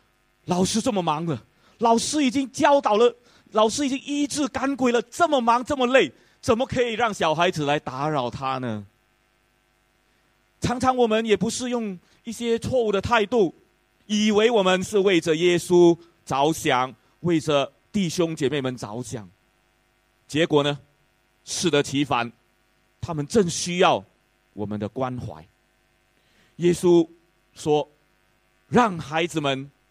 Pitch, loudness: 170 Hz, -23 LUFS